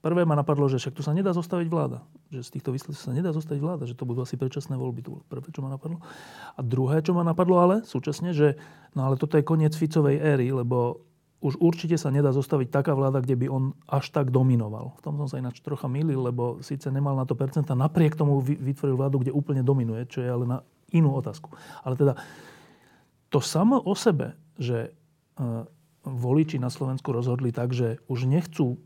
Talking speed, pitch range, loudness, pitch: 210 wpm, 130-155 Hz, -26 LUFS, 140 Hz